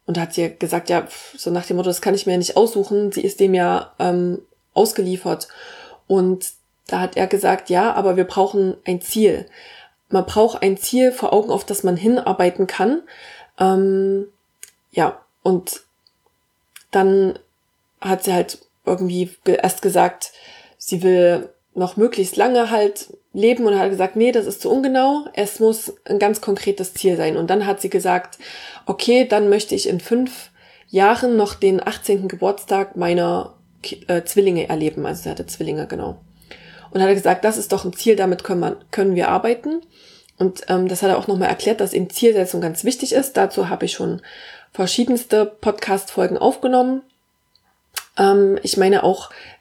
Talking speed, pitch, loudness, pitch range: 165 wpm, 195 Hz, -19 LUFS, 185-220 Hz